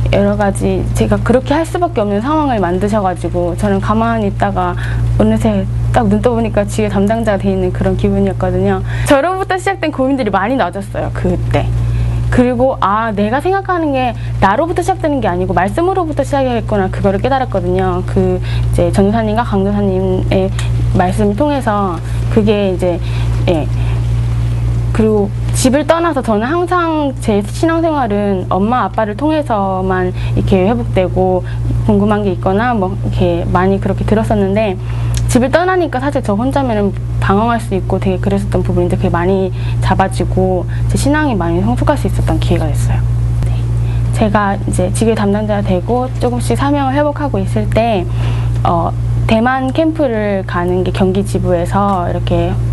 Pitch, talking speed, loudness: 115 Hz, 345 characters per minute, -14 LUFS